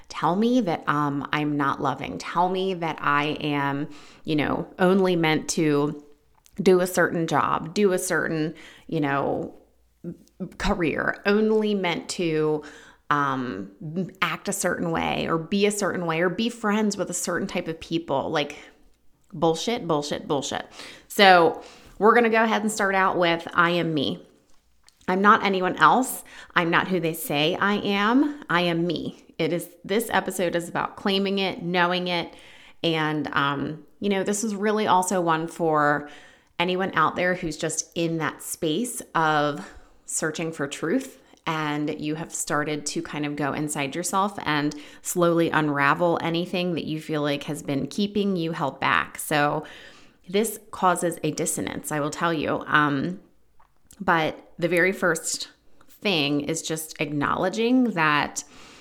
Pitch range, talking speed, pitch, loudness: 150-190 Hz, 155 wpm, 170 Hz, -24 LUFS